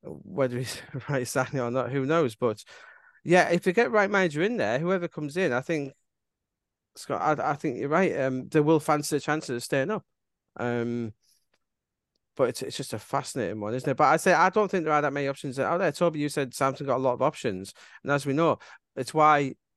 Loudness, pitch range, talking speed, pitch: -26 LUFS, 130-165 Hz, 230 wpm, 145 Hz